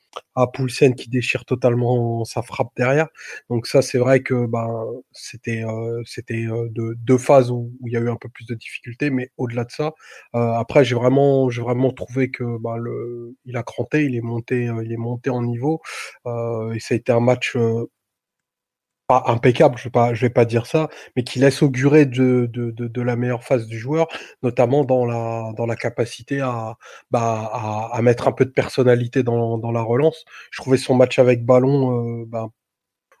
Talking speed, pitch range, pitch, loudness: 210 wpm, 115-130 Hz, 120 Hz, -20 LUFS